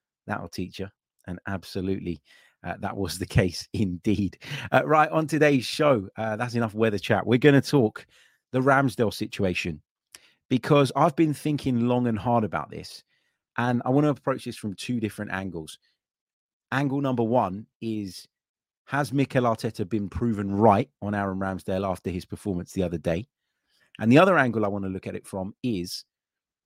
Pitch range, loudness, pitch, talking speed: 95-130 Hz, -25 LUFS, 110 Hz, 175 wpm